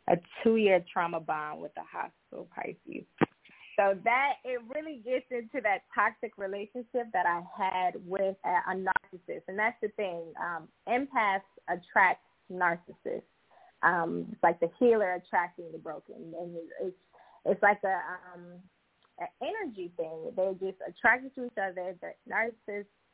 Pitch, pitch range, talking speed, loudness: 195 Hz, 180-225 Hz, 150 wpm, -31 LUFS